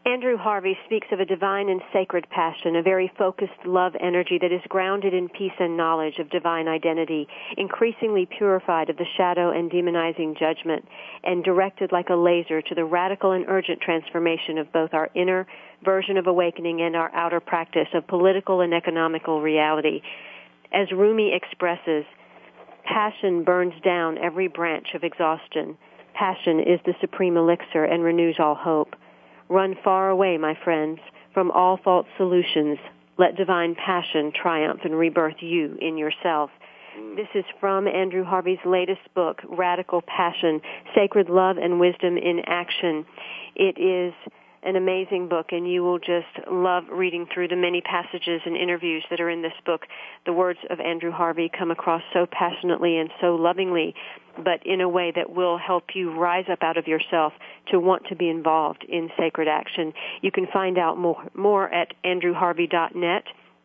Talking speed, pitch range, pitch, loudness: 165 wpm, 165-185 Hz, 175 Hz, -23 LUFS